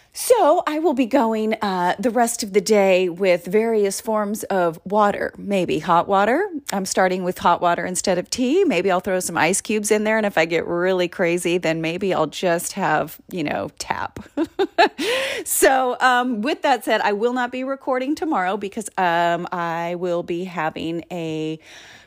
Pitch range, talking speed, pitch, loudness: 175-245 Hz, 180 wpm, 200 Hz, -20 LUFS